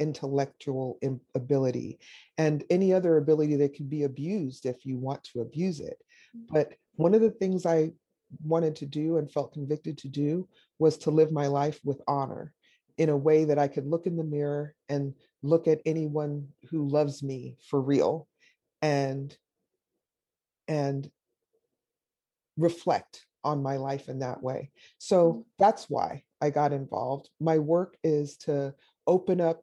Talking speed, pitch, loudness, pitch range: 155 wpm, 150 Hz, -28 LUFS, 140-165 Hz